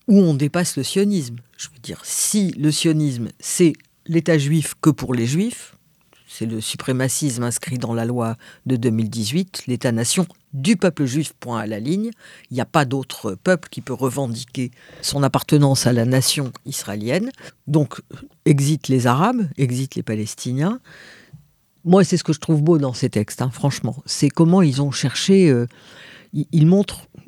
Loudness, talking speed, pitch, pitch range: -20 LUFS, 170 wpm, 145 Hz, 125-165 Hz